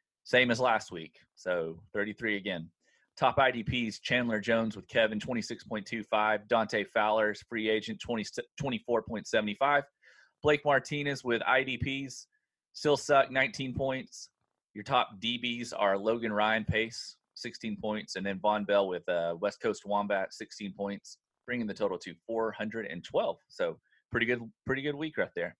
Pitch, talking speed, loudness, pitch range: 115 Hz, 145 wpm, -31 LUFS, 105-130 Hz